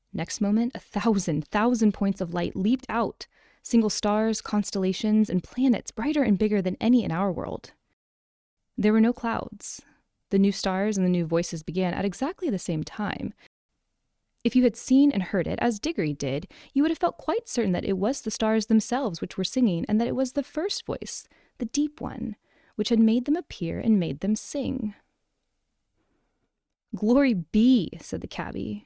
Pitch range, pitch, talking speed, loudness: 190-245 Hz, 215 Hz, 185 wpm, -26 LUFS